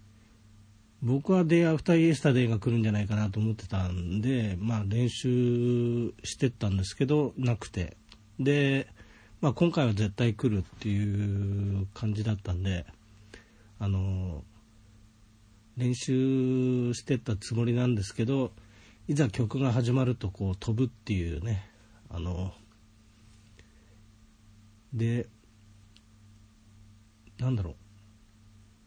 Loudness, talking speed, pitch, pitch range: -29 LUFS, 240 characters per minute, 110 Hz, 105-120 Hz